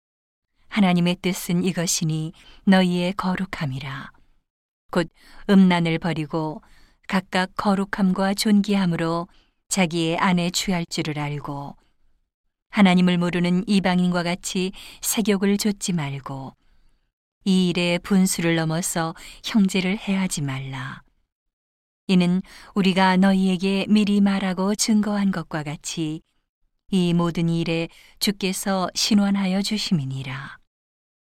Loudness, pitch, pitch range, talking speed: -22 LUFS, 180 Hz, 165-195 Hz, 235 characters per minute